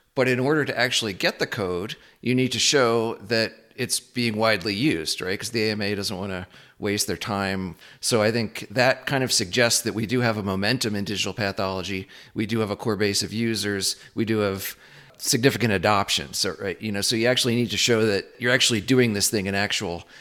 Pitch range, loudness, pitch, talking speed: 100-120 Hz, -23 LUFS, 110 Hz, 220 wpm